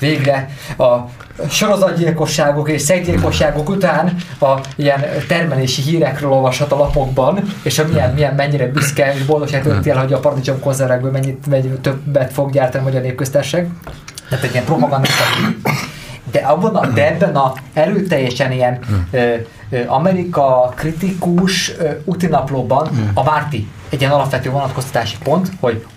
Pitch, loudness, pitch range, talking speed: 140 Hz, -15 LUFS, 130-155 Hz, 125 wpm